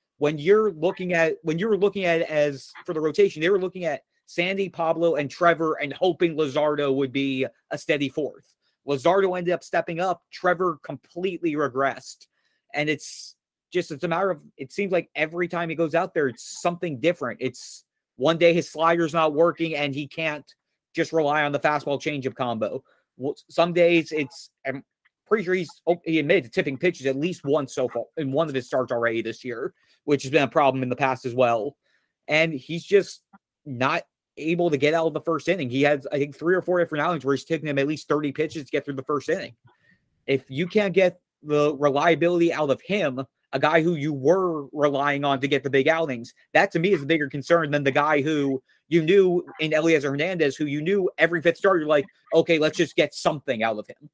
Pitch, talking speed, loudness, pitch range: 155 Hz, 220 wpm, -24 LUFS, 145-175 Hz